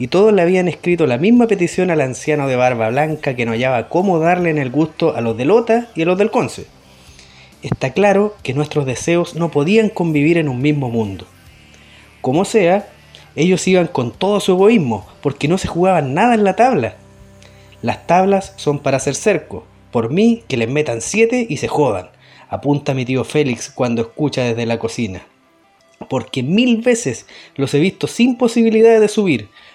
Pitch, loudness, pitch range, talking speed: 150 Hz, -16 LUFS, 120-190 Hz, 185 wpm